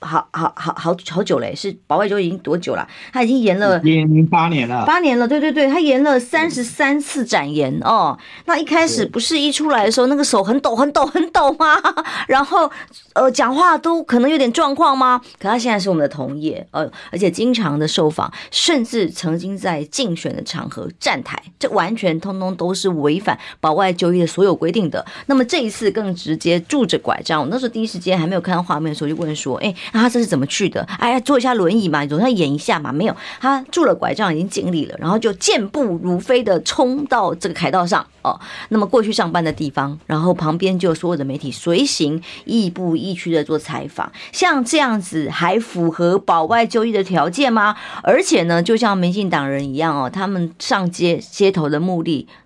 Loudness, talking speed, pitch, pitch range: -17 LUFS, 315 characters per minute, 195 Hz, 165-250 Hz